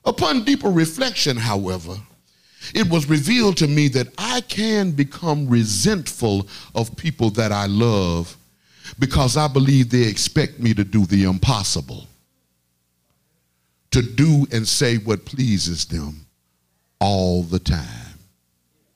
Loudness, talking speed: -19 LUFS, 125 wpm